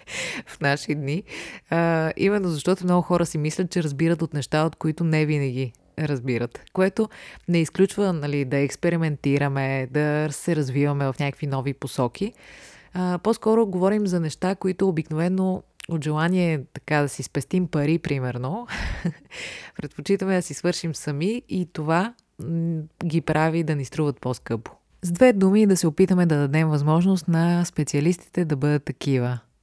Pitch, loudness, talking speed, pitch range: 160 Hz, -24 LUFS, 150 wpm, 145-180 Hz